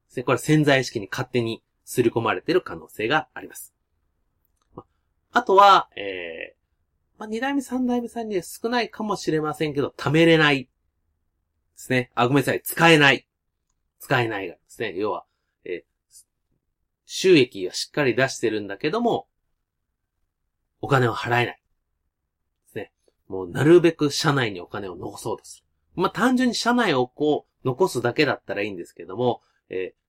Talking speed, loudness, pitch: 310 characters per minute, -22 LUFS, 145 Hz